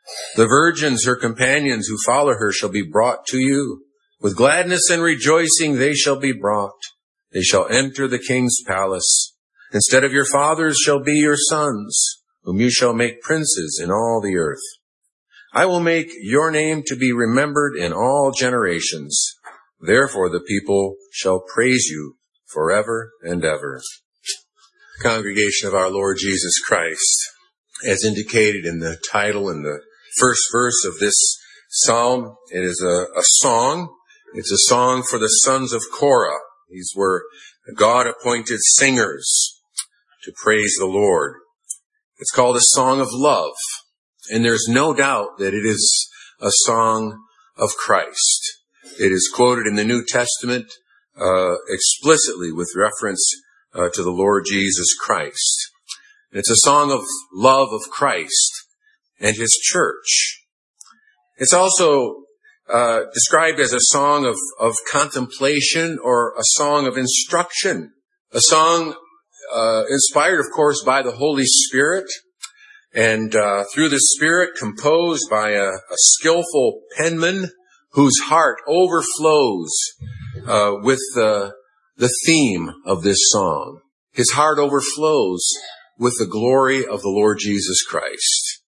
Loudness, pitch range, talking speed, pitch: -17 LUFS, 110-160 Hz, 140 wpm, 130 Hz